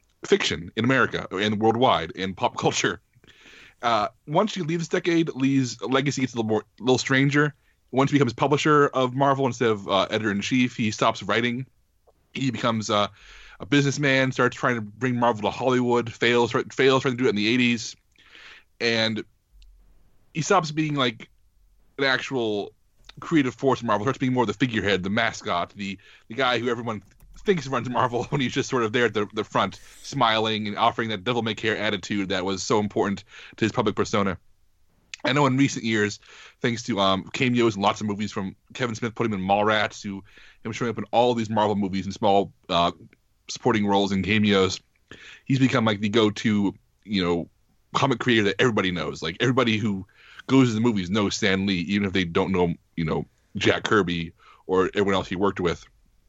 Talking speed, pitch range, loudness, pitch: 195 wpm, 100-130 Hz, -24 LUFS, 115 Hz